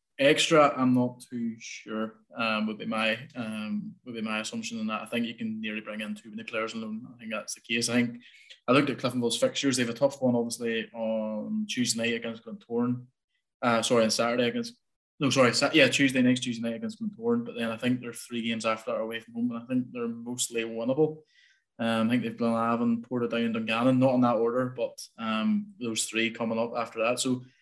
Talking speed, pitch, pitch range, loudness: 230 wpm, 120 Hz, 115-130 Hz, -28 LUFS